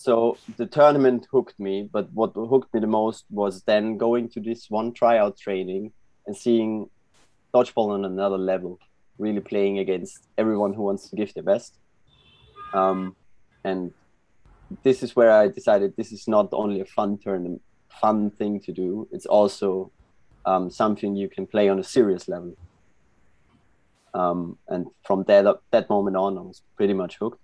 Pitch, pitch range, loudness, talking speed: 105 Hz, 95-115 Hz, -23 LUFS, 165 wpm